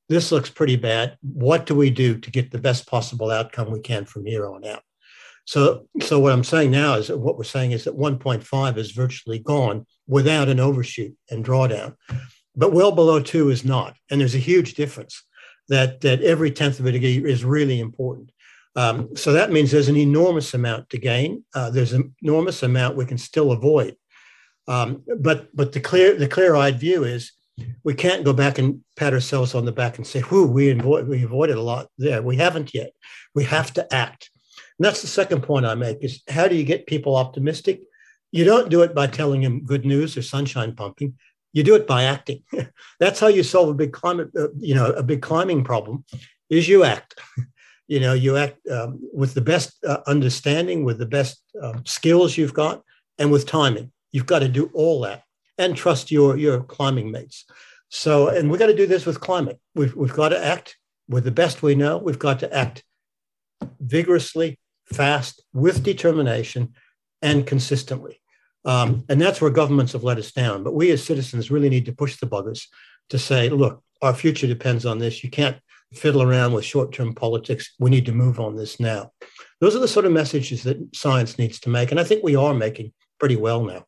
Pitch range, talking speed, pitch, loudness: 125-155 Hz, 205 wpm, 140 Hz, -20 LUFS